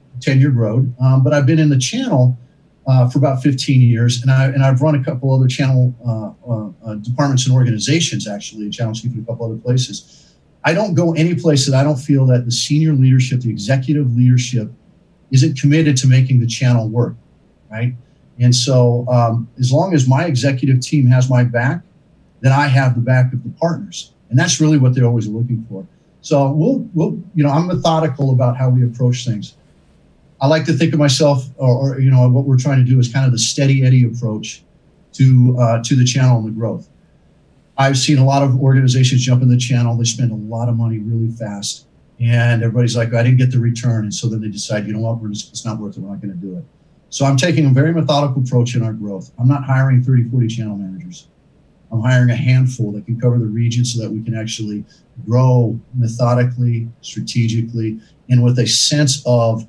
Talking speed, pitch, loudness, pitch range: 220 wpm, 125 Hz, -15 LUFS, 120-140 Hz